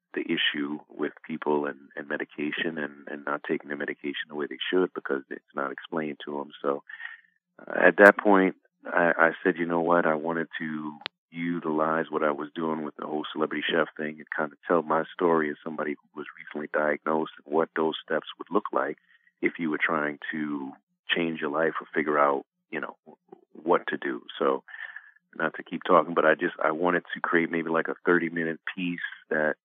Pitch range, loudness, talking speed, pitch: 75-85 Hz, -27 LUFS, 200 wpm, 80 Hz